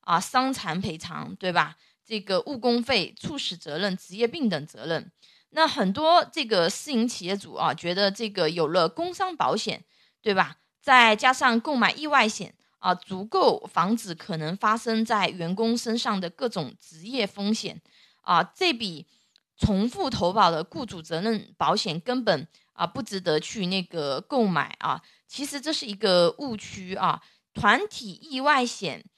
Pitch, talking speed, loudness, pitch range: 210 Hz, 235 characters per minute, -25 LUFS, 180-250 Hz